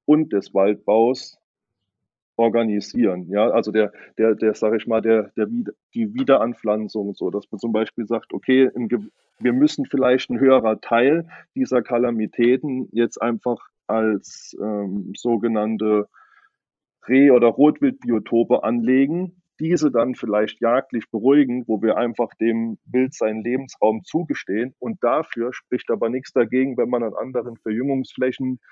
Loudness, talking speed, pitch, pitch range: -21 LUFS, 135 wpm, 115 Hz, 110-130 Hz